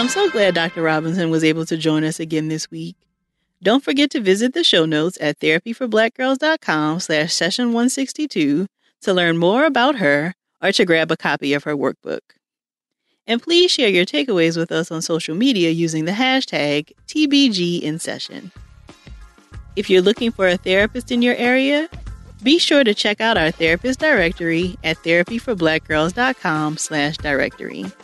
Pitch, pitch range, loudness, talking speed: 175 Hz, 160-245 Hz, -18 LUFS, 160 wpm